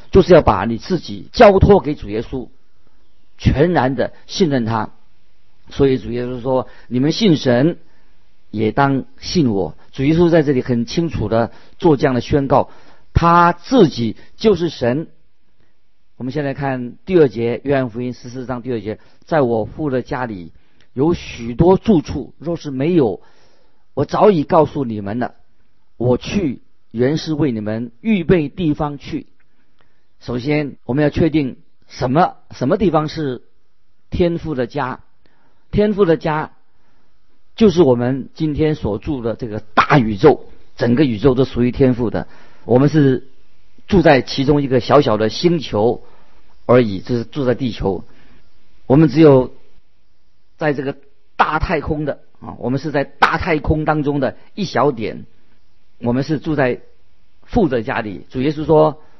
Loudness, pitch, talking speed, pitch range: -17 LUFS, 130 Hz, 215 characters per minute, 115-155 Hz